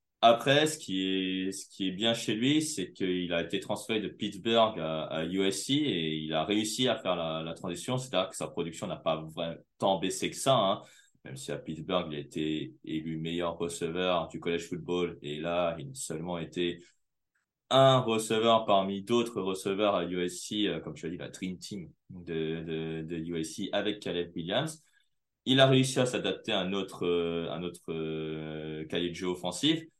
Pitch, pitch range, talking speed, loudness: 90 Hz, 80-105 Hz, 195 wpm, -31 LUFS